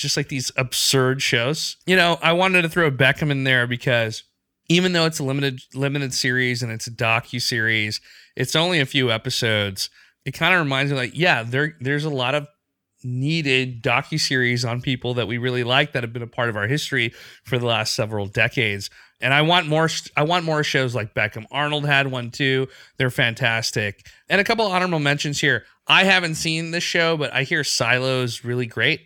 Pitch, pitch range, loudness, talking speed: 135 Hz, 120-150 Hz, -20 LUFS, 205 wpm